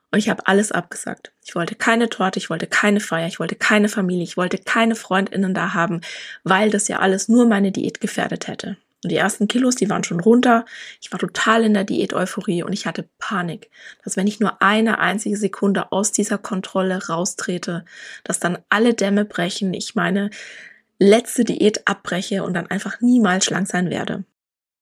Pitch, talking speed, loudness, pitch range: 200 Hz, 190 wpm, -19 LUFS, 185-215 Hz